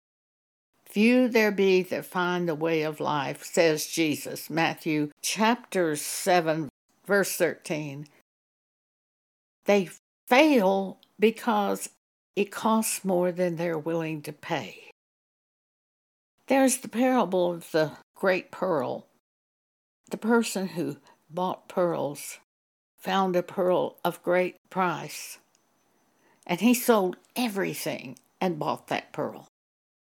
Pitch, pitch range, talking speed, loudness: 180 Hz, 160-220 Hz, 105 wpm, -26 LUFS